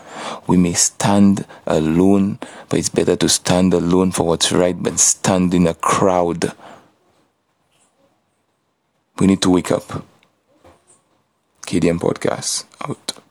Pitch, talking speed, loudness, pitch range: 90 Hz, 115 wpm, -16 LUFS, 85-95 Hz